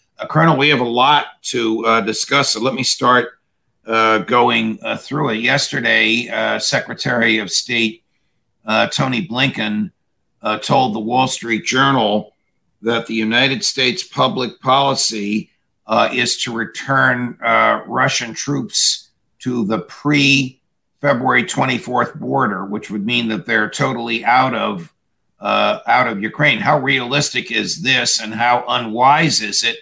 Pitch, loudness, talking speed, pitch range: 115 Hz, -16 LUFS, 140 wpm, 110-120 Hz